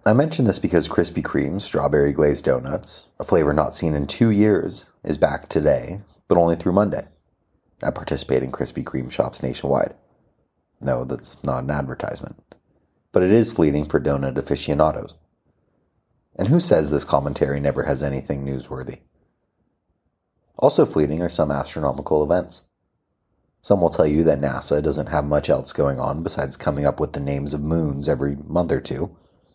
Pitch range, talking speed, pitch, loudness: 70-80 Hz, 165 wpm, 75 Hz, -21 LUFS